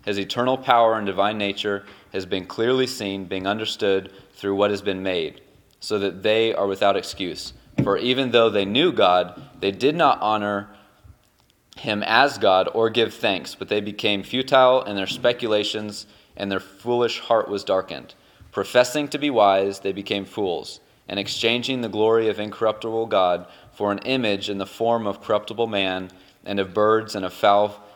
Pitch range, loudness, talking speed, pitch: 100-115 Hz, -22 LUFS, 175 wpm, 105 Hz